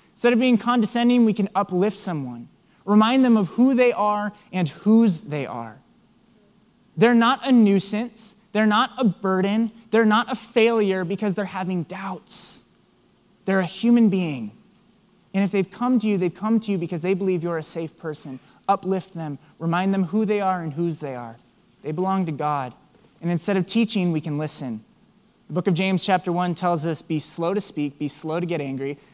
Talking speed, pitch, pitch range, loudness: 195 wpm, 190 Hz, 170-215 Hz, -22 LUFS